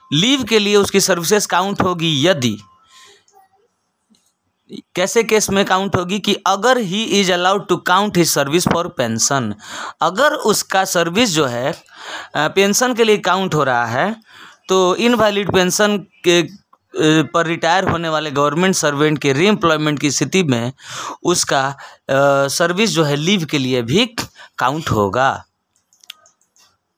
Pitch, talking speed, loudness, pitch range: 180 Hz, 140 wpm, -16 LUFS, 145-200 Hz